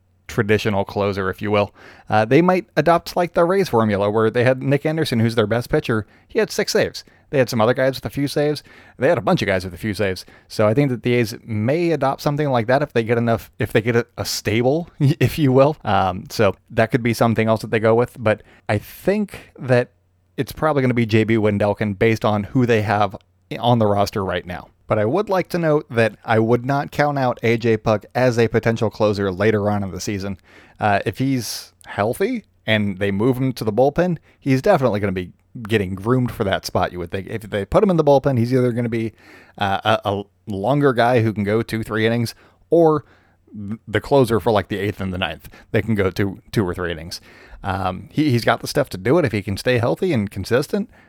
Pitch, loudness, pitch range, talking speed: 115 Hz, -19 LUFS, 105-130 Hz, 240 wpm